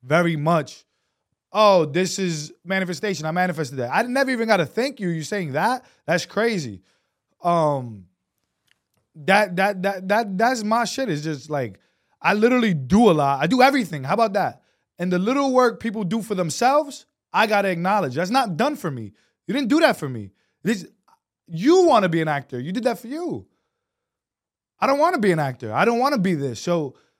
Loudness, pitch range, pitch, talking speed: -21 LUFS, 155-230 Hz, 190 Hz, 190 wpm